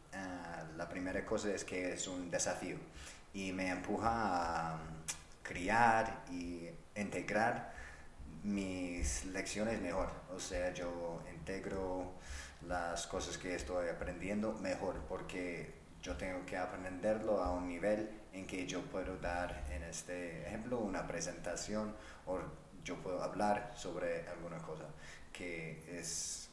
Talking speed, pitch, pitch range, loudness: 125 wpm, 90 Hz, 80-95 Hz, -41 LUFS